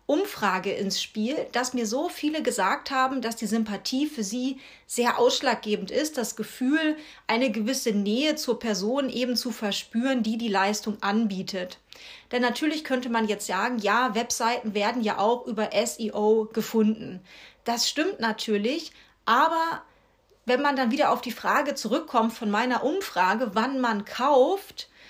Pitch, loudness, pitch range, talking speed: 235 Hz, -26 LUFS, 215-265 Hz, 150 wpm